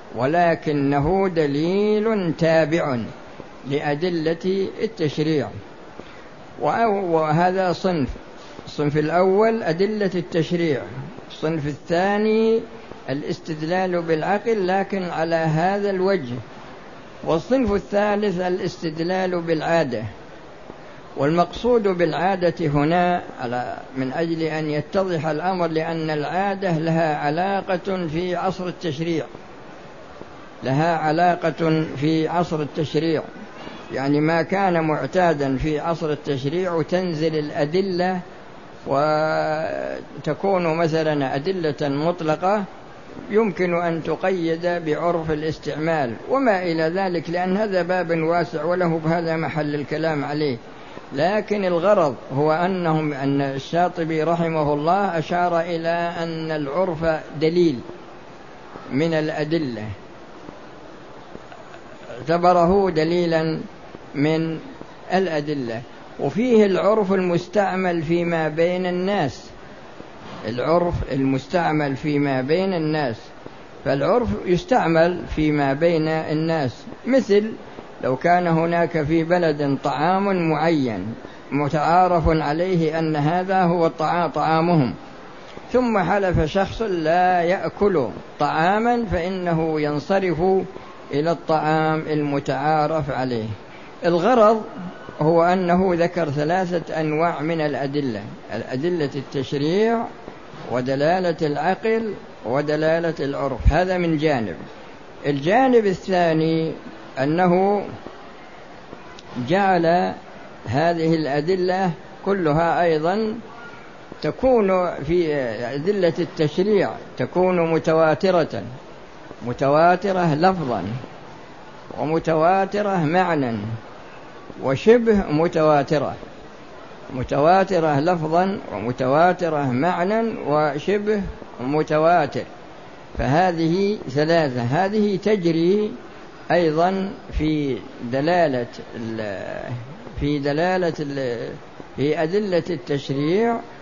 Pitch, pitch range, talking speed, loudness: 165 Hz, 150-185 Hz, 80 wpm, -21 LUFS